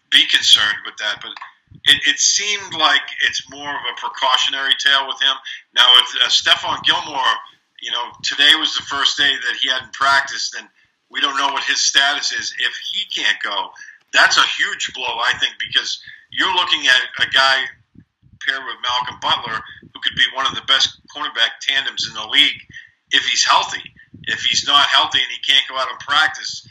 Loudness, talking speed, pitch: -15 LUFS, 195 wpm, 175 Hz